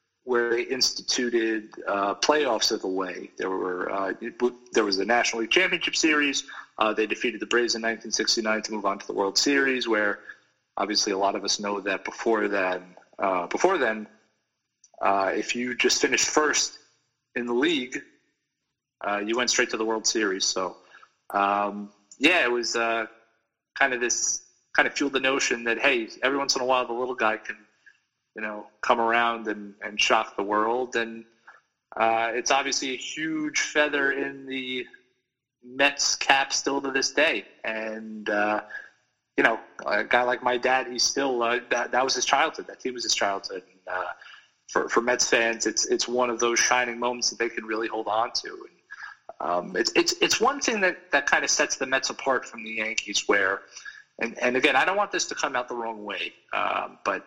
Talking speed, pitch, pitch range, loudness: 195 wpm, 115 Hz, 110-130 Hz, -25 LUFS